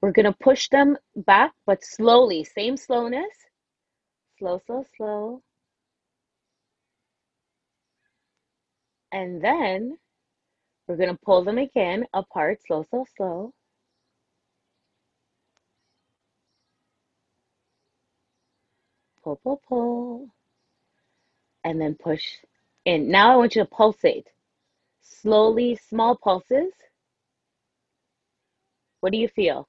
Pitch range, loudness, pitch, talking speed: 195-255 Hz, -22 LUFS, 225 Hz, 85 wpm